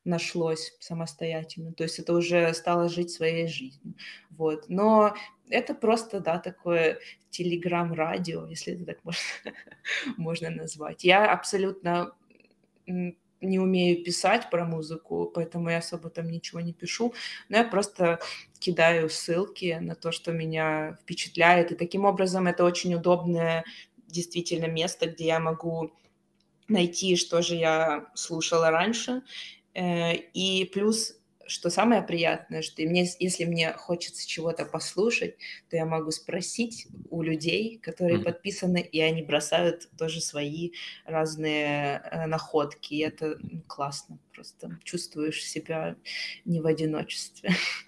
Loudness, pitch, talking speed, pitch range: -28 LUFS, 170 Hz, 125 wpm, 160-180 Hz